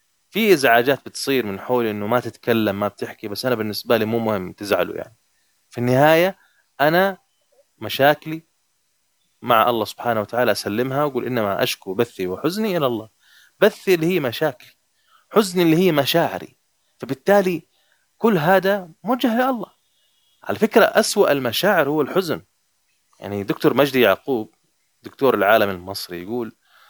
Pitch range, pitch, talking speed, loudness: 115-180 Hz, 135 Hz, 140 wpm, -20 LUFS